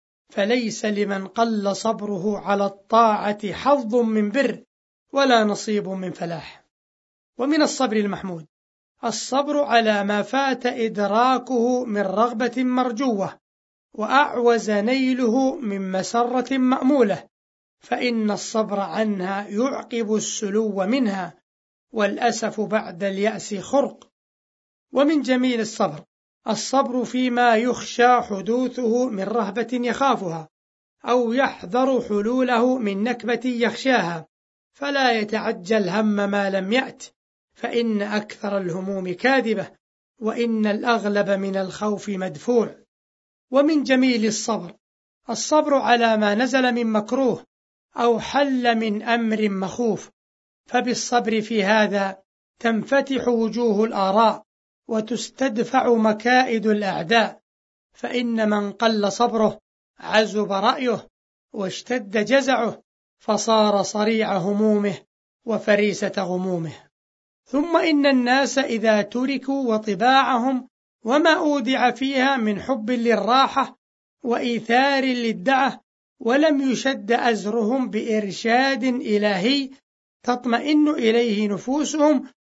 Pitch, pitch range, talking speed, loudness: 230 Hz, 205-255 Hz, 95 wpm, -21 LUFS